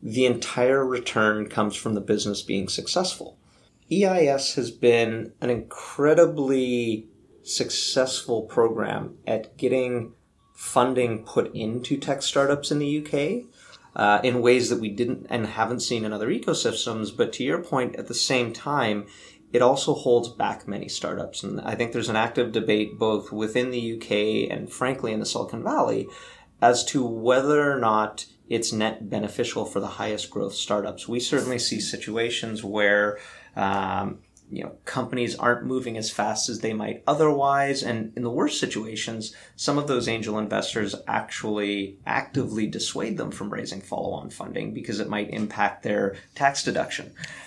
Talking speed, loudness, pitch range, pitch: 155 wpm, -25 LUFS, 110-125 Hz, 115 Hz